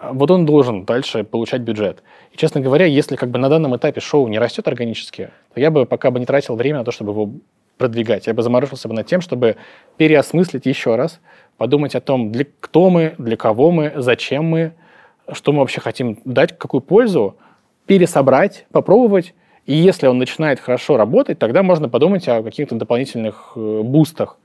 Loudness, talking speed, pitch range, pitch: -16 LUFS, 185 wpm, 120-155 Hz, 135 Hz